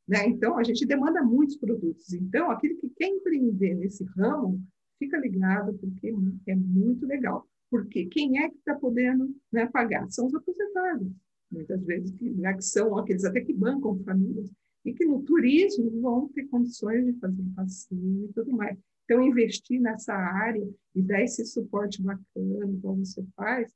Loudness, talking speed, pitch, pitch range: -27 LUFS, 170 wpm, 225 Hz, 195-255 Hz